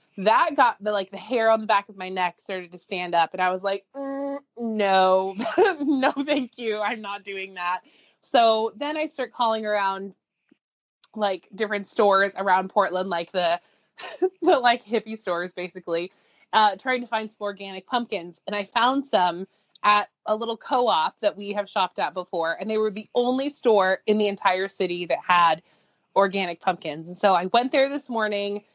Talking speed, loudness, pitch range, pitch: 185 wpm, -24 LUFS, 190-235 Hz, 205 Hz